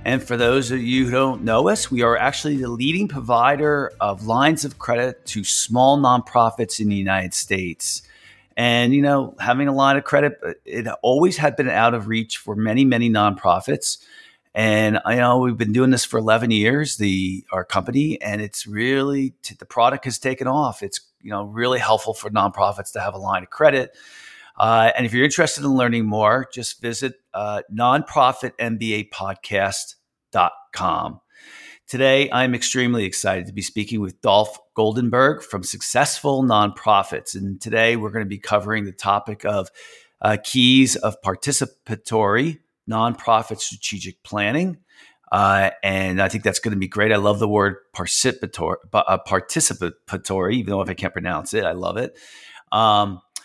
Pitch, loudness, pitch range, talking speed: 115 Hz, -20 LUFS, 105-130 Hz, 165 wpm